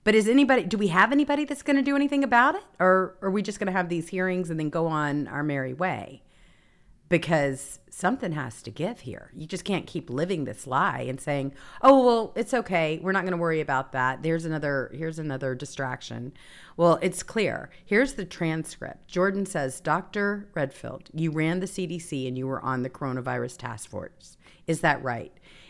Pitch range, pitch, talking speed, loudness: 135-195 Hz, 165 Hz, 205 wpm, -26 LUFS